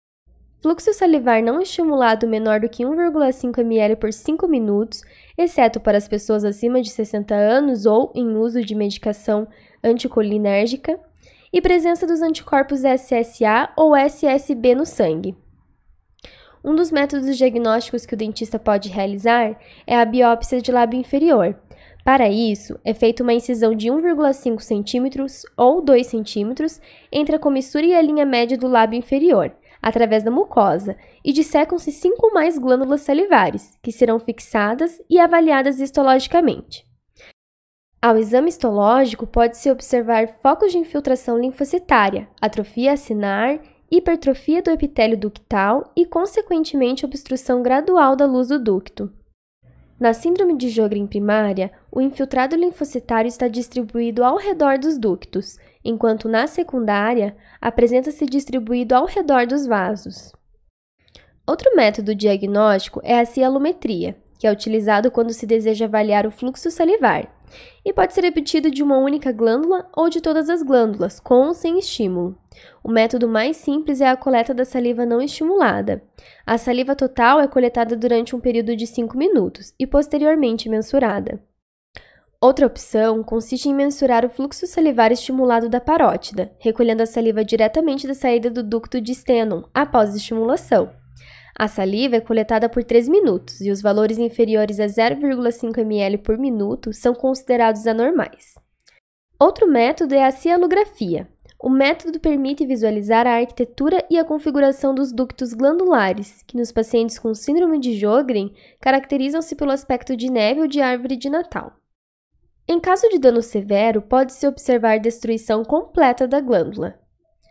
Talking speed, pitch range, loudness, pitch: 140 wpm, 225-290 Hz, -18 LUFS, 250 Hz